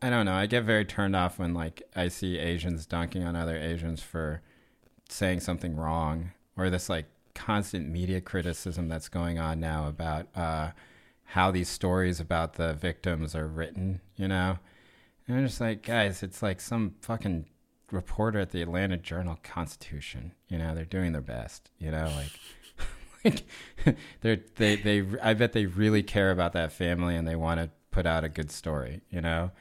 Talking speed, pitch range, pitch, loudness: 180 wpm, 80-95 Hz, 90 Hz, -30 LUFS